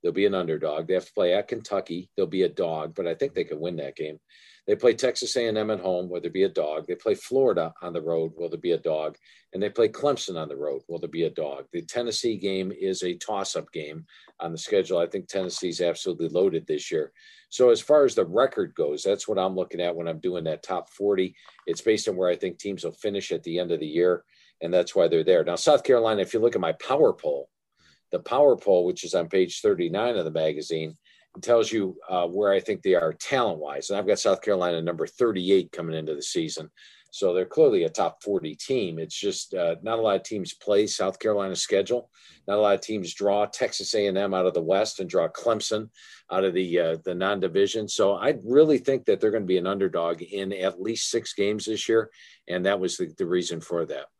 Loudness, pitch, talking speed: -25 LUFS, 135 Hz, 240 wpm